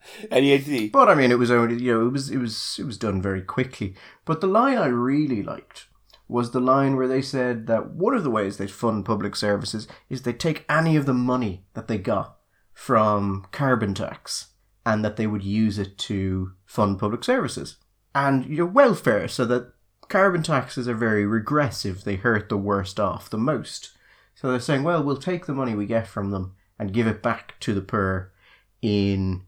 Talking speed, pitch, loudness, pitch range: 200 wpm, 115 Hz, -23 LUFS, 100-130 Hz